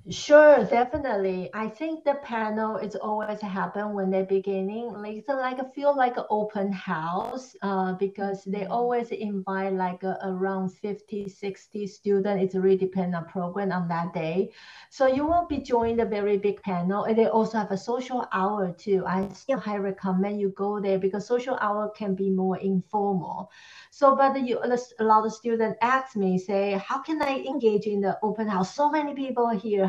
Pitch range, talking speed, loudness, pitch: 195-235 Hz, 185 wpm, -26 LUFS, 205 Hz